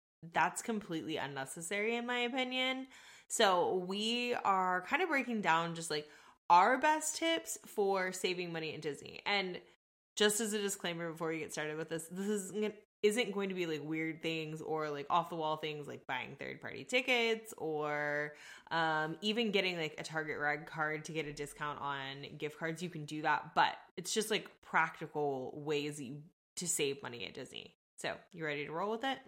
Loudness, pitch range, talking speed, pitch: -36 LUFS, 155-210 Hz, 185 wpm, 170 Hz